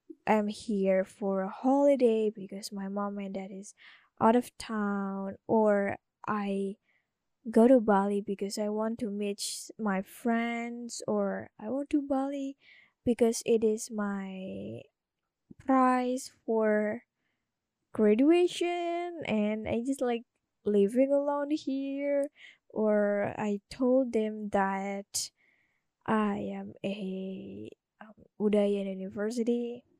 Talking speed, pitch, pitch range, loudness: 110 wpm, 215 Hz, 200-250 Hz, -30 LUFS